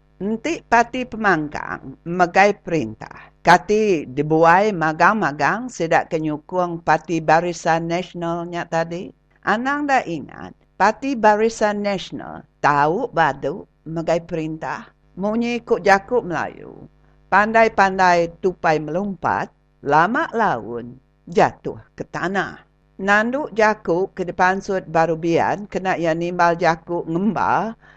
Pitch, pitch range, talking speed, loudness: 175 Hz, 165-210 Hz, 95 wpm, -19 LUFS